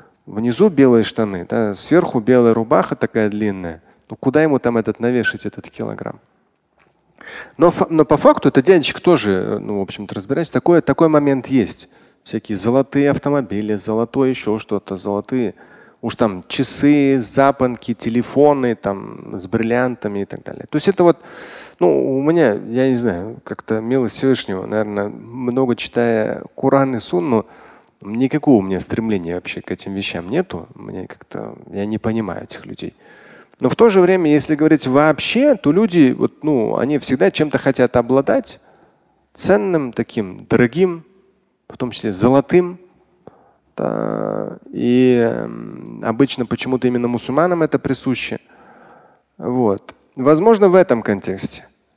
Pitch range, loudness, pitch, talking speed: 110-150 Hz, -17 LUFS, 125 Hz, 140 wpm